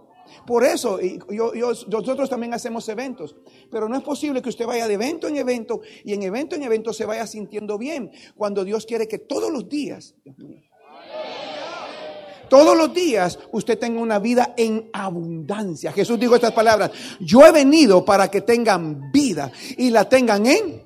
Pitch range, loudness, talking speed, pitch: 210-260 Hz, -19 LUFS, 170 wpm, 230 Hz